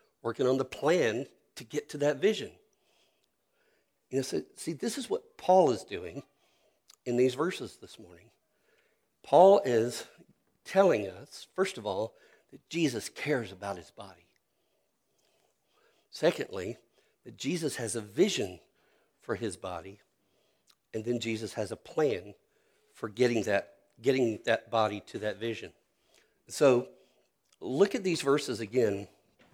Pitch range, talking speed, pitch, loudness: 110-150 Hz, 135 wpm, 120 Hz, -30 LUFS